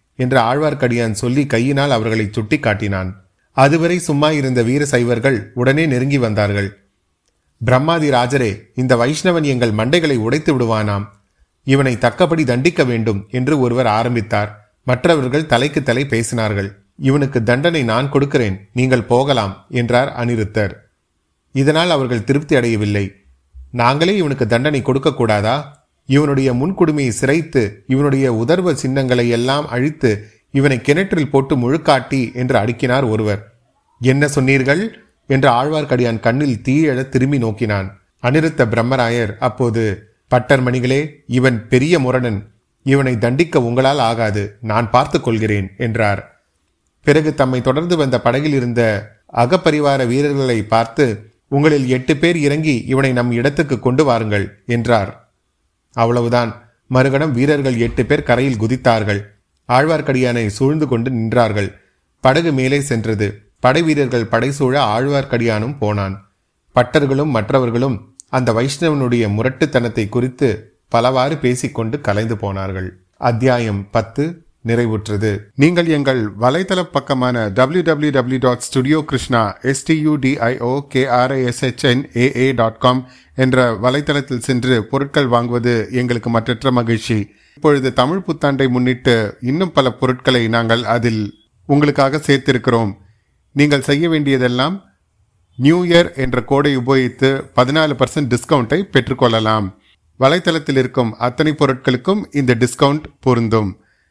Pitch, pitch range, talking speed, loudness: 125 Hz, 115-140 Hz, 110 wpm, -16 LUFS